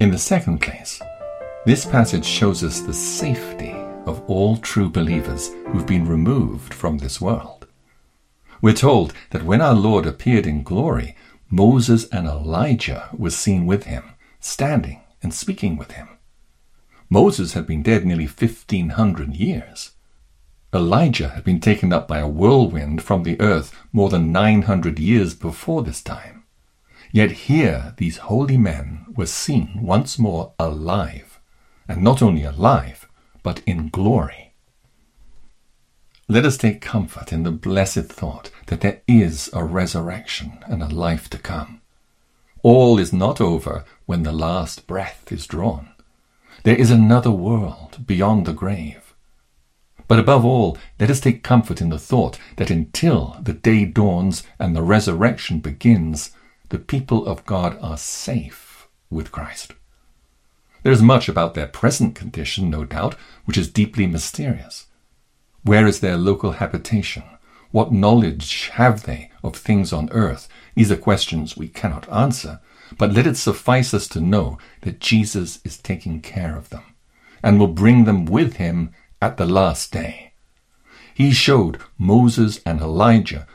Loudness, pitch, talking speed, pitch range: -18 LUFS, 95 Hz, 150 wpm, 80-110 Hz